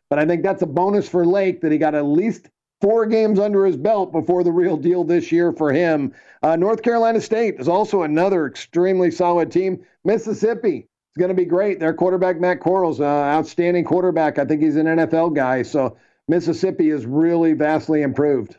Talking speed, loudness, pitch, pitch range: 195 wpm, -19 LUFS, 175 Hz, 155-185 Hz